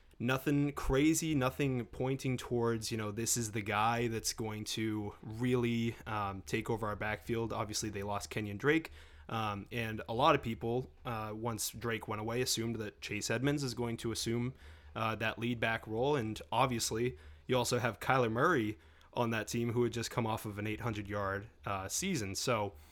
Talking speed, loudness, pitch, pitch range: 185 wpm, -35 LUFS, 115 Hz, 105-125 Hz